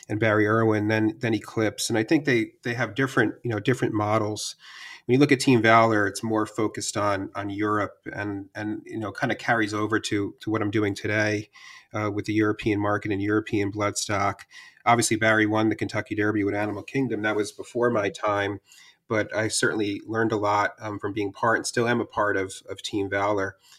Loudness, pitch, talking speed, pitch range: -25 LUFS, 105 Hz, 210 wpm, 105-110 Hz